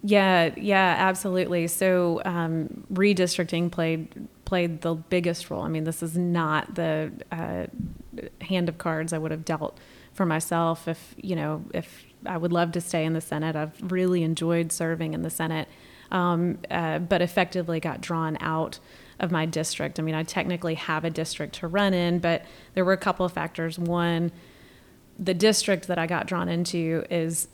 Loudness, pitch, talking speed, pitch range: -26 LUFS, 170 Hz, 180 wpm, 160-180 Hz